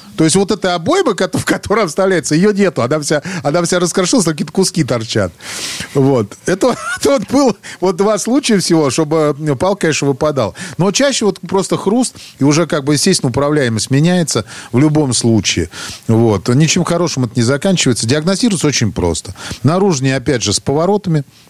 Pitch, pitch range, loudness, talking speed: 160 Hz, 135-190 Hz, -14 LUFS, 170 wpm